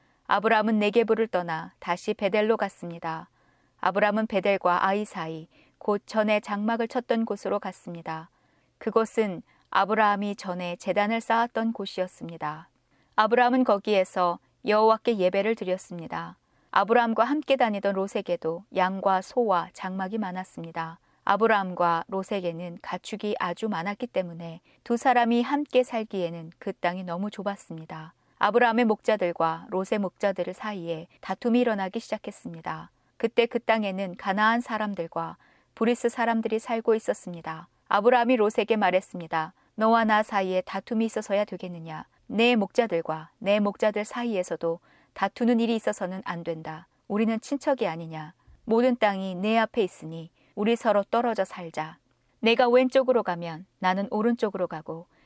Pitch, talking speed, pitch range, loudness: 200 Hz, 340 characters per minute, 175-225 Hz, -26 LUFS